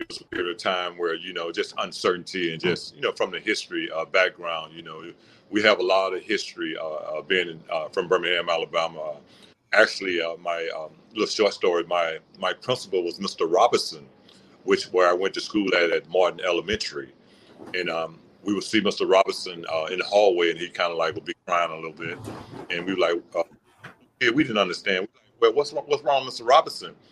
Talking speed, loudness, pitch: 210 wpm, -24 LUFS, 355 Hz